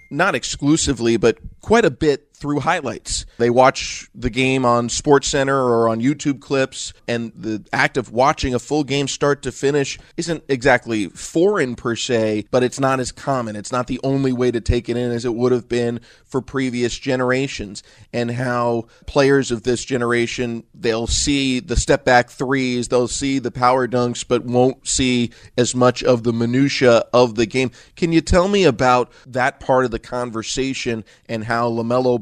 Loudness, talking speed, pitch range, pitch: -19 LUFS, 180 wpm, 120-135 Hz, 125 Hz